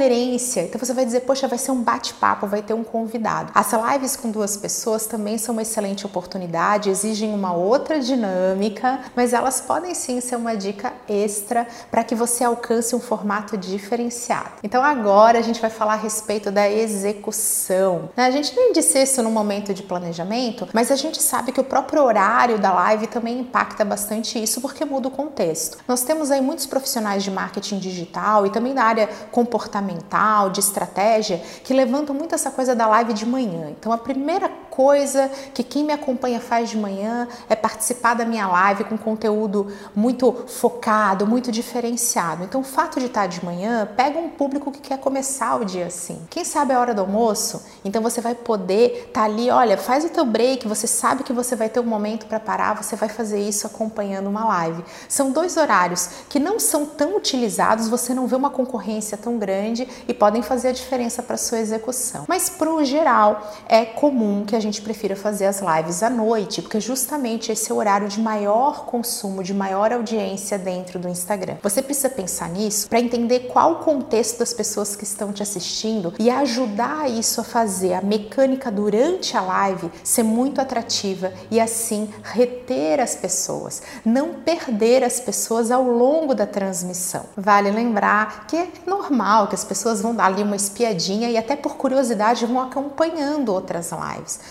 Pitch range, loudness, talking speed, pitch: 205-255 Hz, -21 LUFS, 185 wpm, 230 Hz